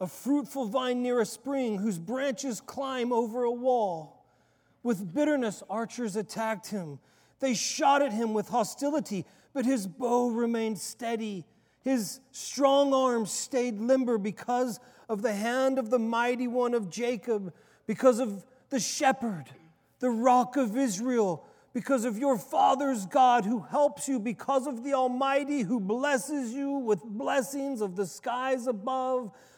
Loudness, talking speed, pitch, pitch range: -29 LUFS, 145 wpm, 245 Hz, 220-265 Hz